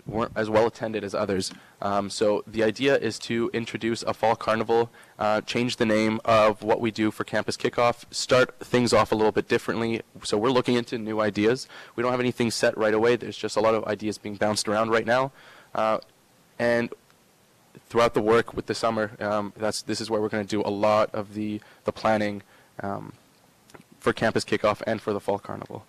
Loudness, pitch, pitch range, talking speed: -25 LUFS, 110 Hz, 105-120 Hz, 210 wpm